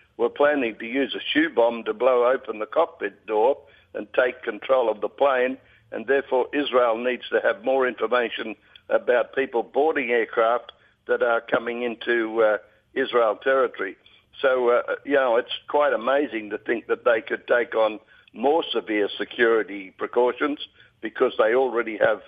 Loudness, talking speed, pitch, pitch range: -23 LUFS, 160 wpm, 125 Hz, 115-145 Hz